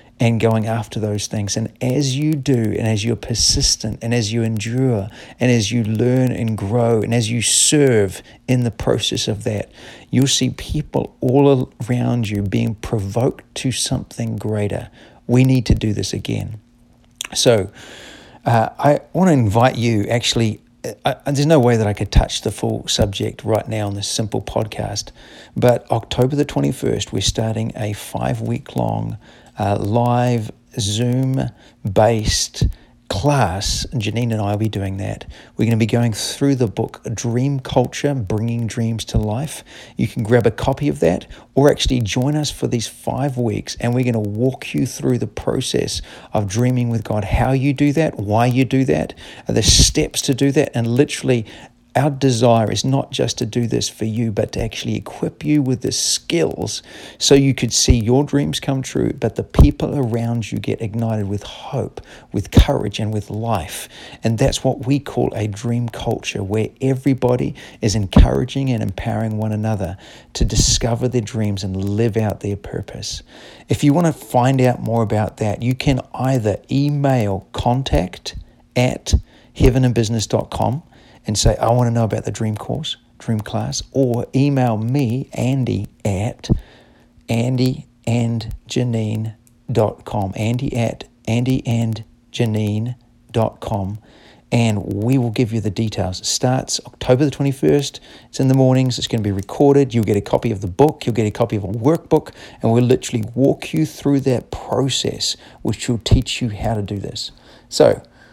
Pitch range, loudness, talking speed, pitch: 110-130 Hz, -19 LUFS, 170 wpm, 115 Hz